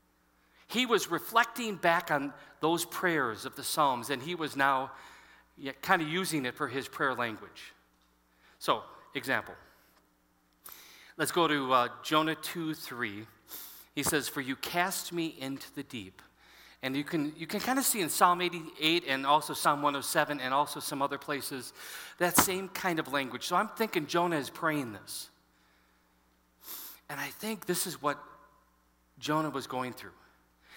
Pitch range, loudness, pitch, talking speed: 120-170 Hz, -31 LUFS, 145 Hz, 160 wpm